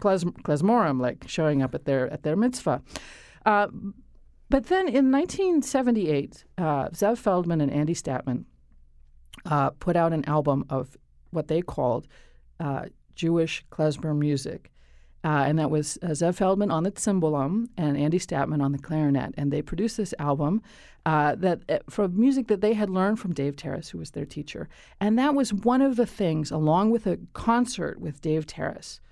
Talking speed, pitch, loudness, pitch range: 175 wpm, 160 Hz, -26 LUFS, 145-205 Hz